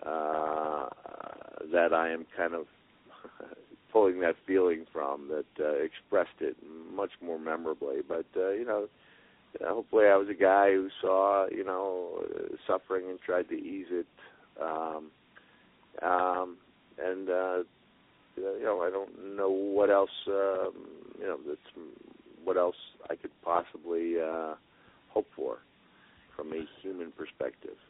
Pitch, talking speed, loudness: 100 Hz, 140 wpm, -31 LUFS